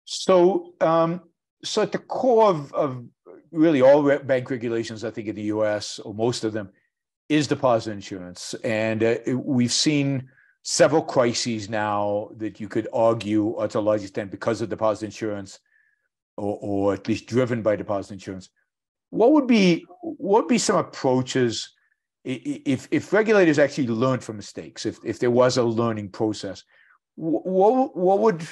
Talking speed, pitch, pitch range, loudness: 165 wpm, 120 Hz, 110-160 Hz, -22 LUFS